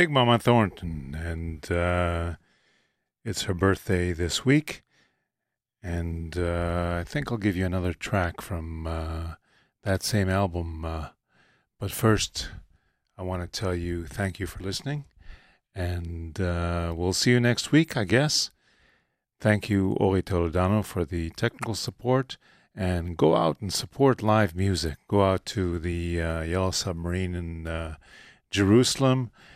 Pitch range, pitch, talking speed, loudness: 85-105 Hz, 90 Hz, 140 wpm, -26 LUFS